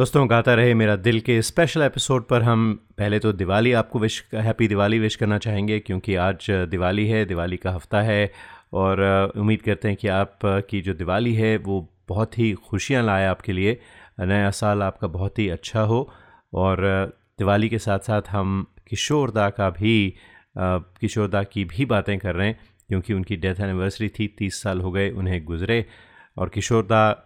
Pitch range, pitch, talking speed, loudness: 95-110 Hz, 105 Hz, 180 wpm, -22 LUFS